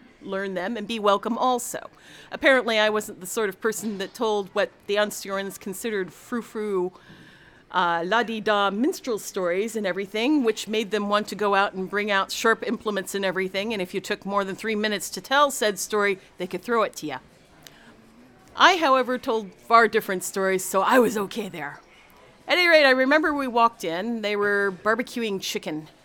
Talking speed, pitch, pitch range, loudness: 195 wpm, 210 Hz, 195-230 Hz, -24 LUFS